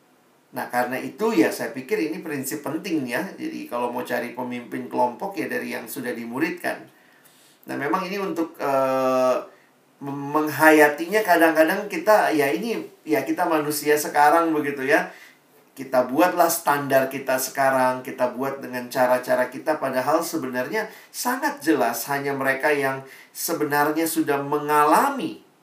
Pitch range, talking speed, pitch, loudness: 130-165 Hz, 135 wpm, 145 Hz, -22 LUFS